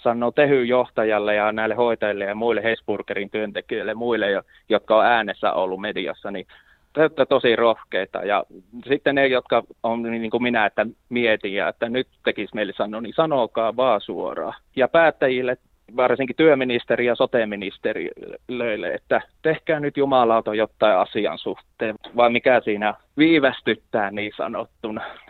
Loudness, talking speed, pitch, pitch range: -21 LUFS, 140 wpm, 120 Hz, 110-135 Hz